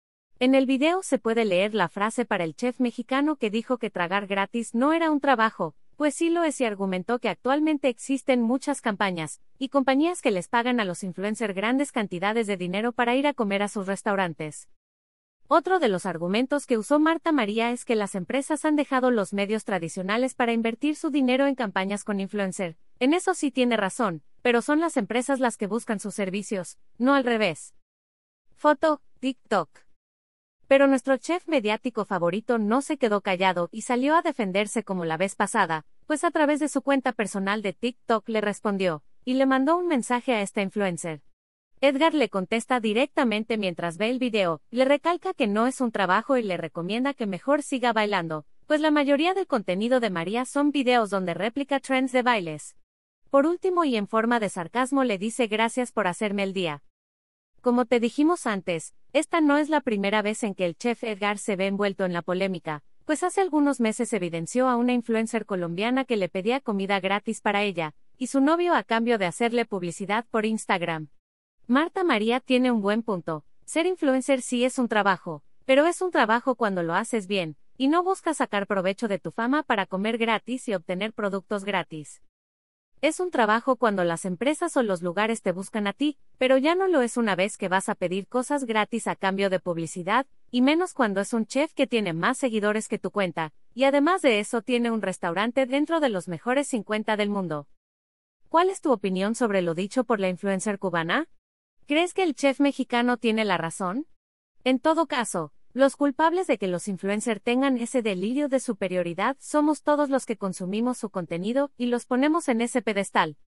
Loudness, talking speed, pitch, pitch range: -25 LUFS, 195 wpm, 230 Hz, 195-270 Hz